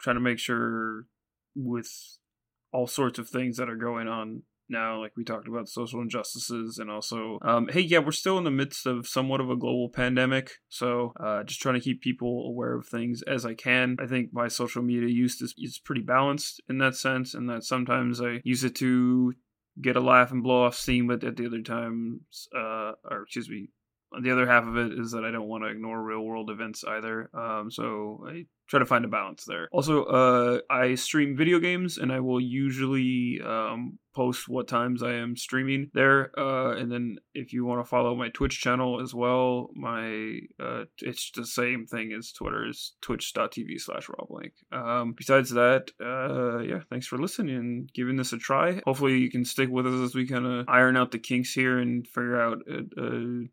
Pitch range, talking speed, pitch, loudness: 115-130 Hz, 205 wpm, 125 Hz, -27 LUFS